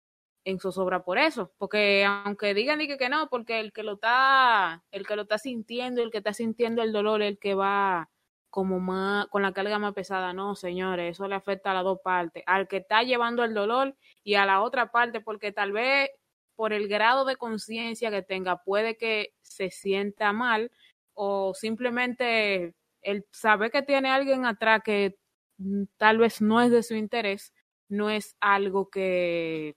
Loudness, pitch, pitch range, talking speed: -26 LUFS, 210 Hz, 195-230 Hz, 185 wpm